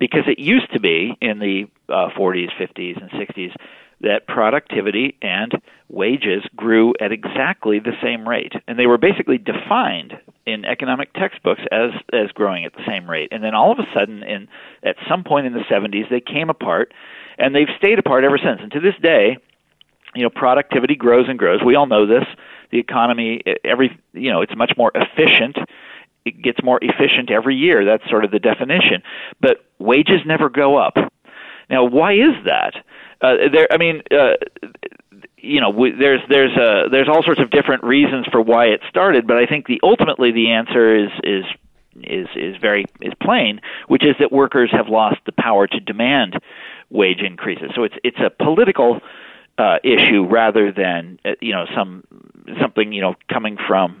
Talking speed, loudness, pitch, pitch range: 185 wpm, -16 LUFS, 125 Hz, 110-160 Hz